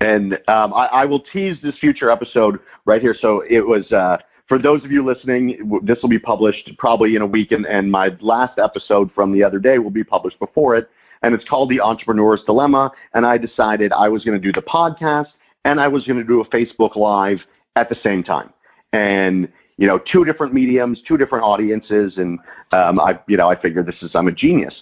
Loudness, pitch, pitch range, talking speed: -16 LUFS, 115 Hz, 105-130 Hz, 225 wpm